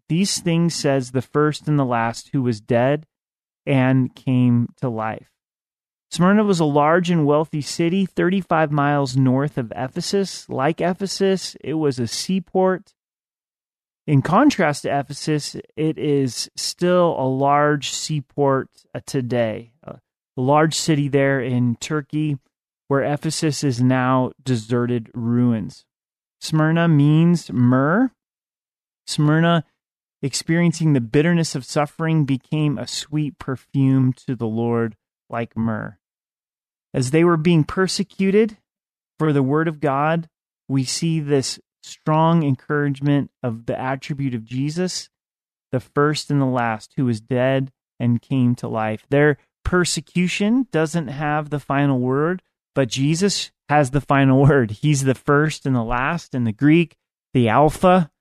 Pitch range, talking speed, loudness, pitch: 130-160 Hz, 135 wpm, -20 LUFS, 145 Hz